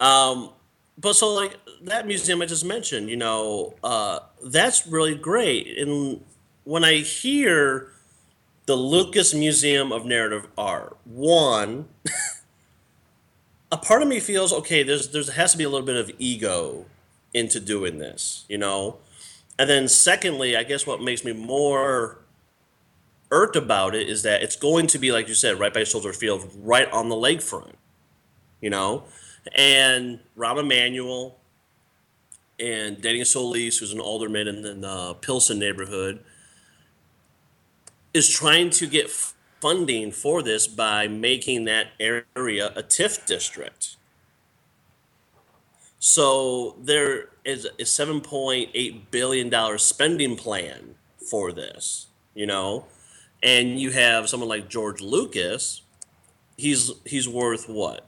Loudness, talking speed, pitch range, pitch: -21 LUFS, 130 wpm, 110-150 Hz, 130 Hz